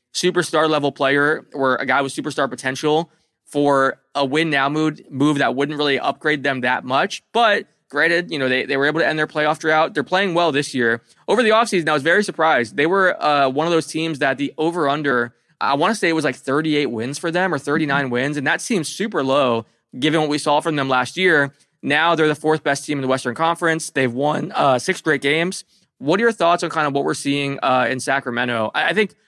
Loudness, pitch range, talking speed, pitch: -19 LUFS, 140-160 Hz, 240 wpm, 150 Hz